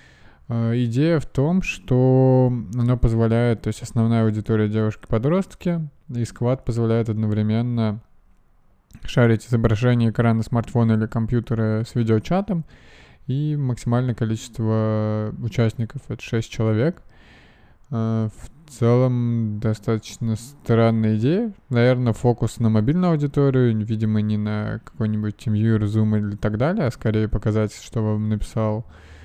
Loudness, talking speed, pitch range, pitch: -21 LUFS, 115 wpm, 110-125 Hz, 115 Hz